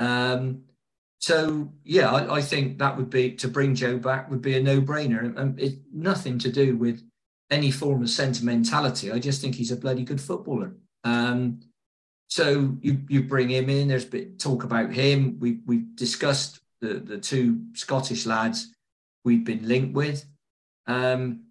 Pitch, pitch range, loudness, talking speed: 130 Hz, 120-140 Hz, -25 LUFS, 175 wpm